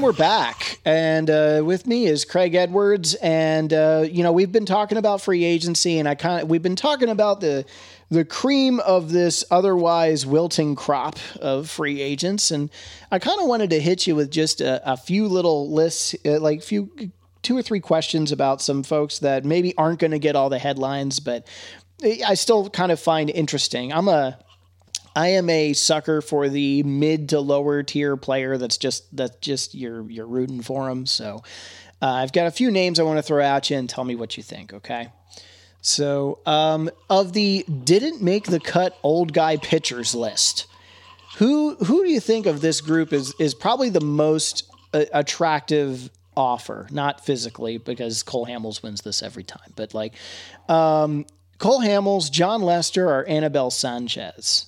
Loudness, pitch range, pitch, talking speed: -21 LUFS, 135-175 Hz, 155 Hz, 185 wpm